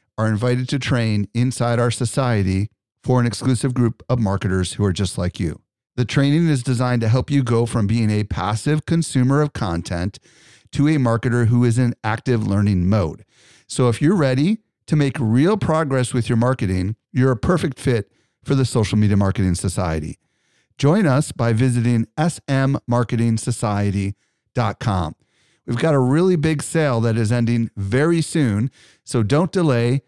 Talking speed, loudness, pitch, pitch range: 165 wpm, -19 LUFS, 120 Hz, 105-140 Hz